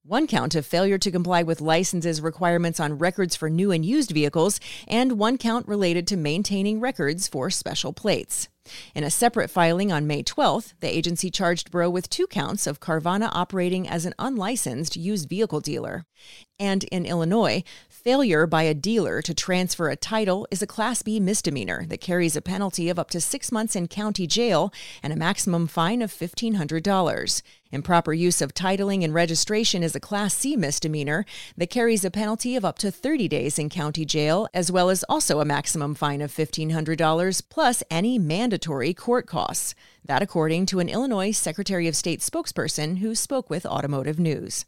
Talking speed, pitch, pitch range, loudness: 180 wpm, 180 Hz, 160-210 Hz, -24 LUFS